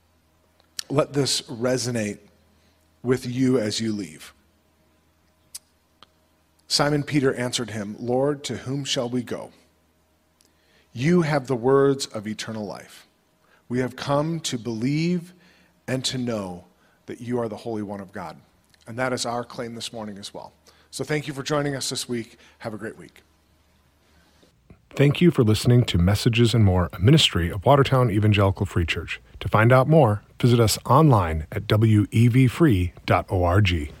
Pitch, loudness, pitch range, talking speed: 110 Hz, -22 LUFS, 85-130 Hz, 150 wpm